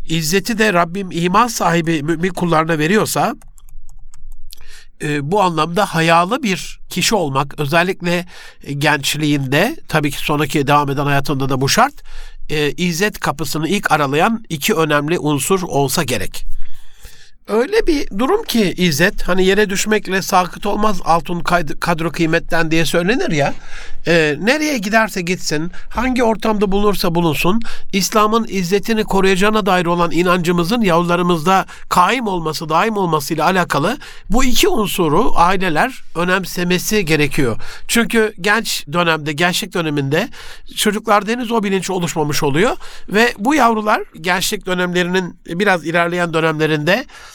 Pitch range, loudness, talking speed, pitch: 160-210 Hz, -16 LUFS, 120 wpm, 180 Hz